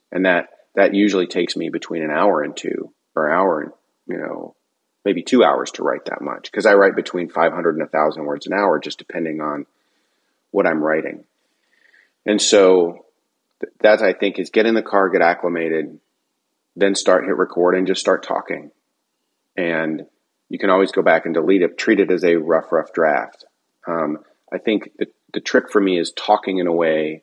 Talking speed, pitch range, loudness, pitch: 200 wpm, 80-95 Hz, -18 LUFS, 85 Hz